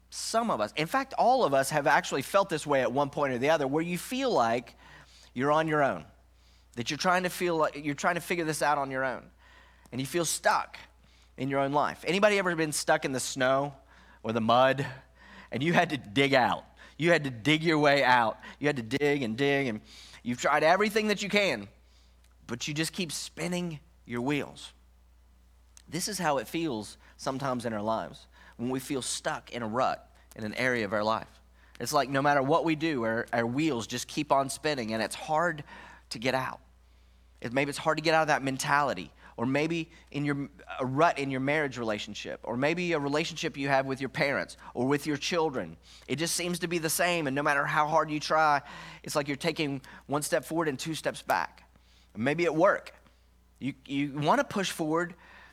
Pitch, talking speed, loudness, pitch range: 140 Hz, 220 wpm, -29 LUFS, 115-160 Hz